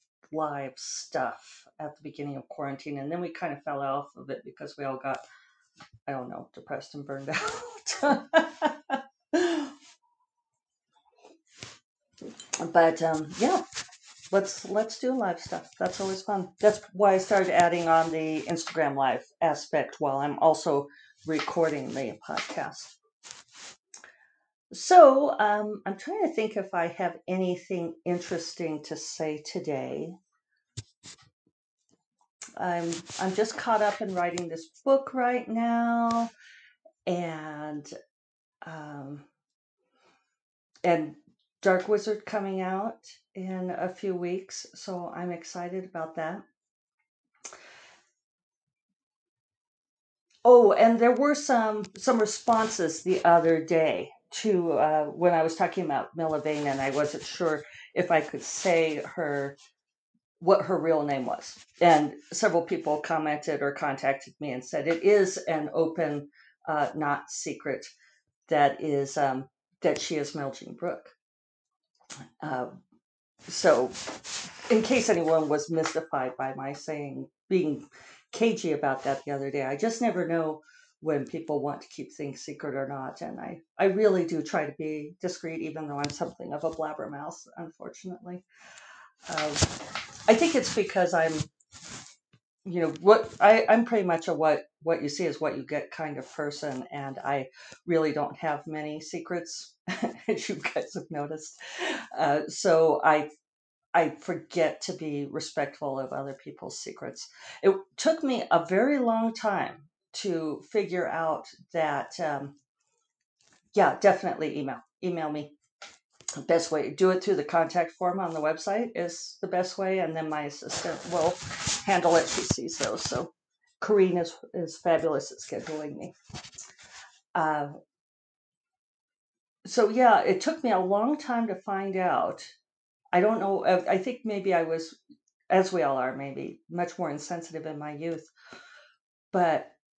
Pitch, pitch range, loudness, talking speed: 170 Hz, 150-210 Hz, -28 LUFS, 140 wpm